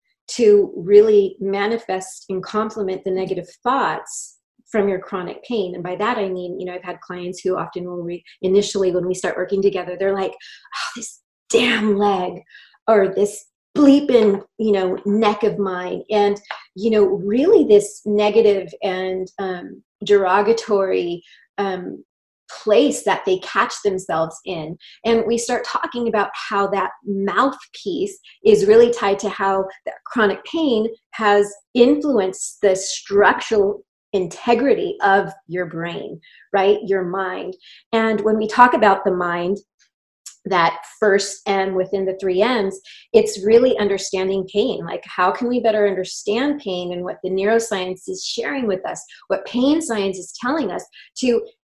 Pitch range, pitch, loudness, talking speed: 190-230 Hz, 205 Hz, -19 LUFS, 150 wpm